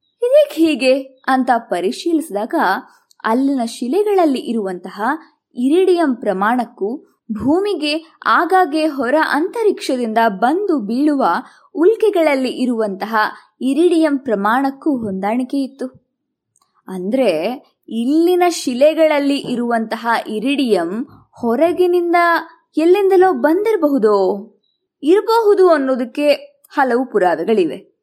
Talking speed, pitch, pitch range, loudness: 70 wpm, 285 Hz, 240-340 Hz, -16 LUFS